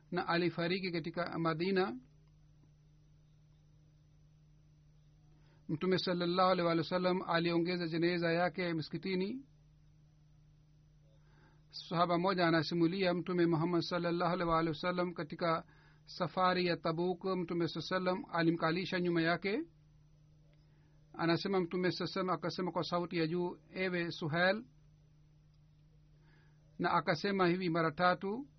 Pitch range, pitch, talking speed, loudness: 150-180 Hz, 170 Hz, 100 wpm, -34 LUFS